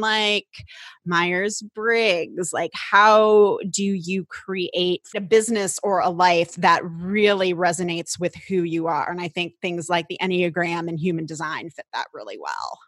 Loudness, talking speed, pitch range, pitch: -21 LUFS, 160 wpm, 175-205 Hz, 180 Hz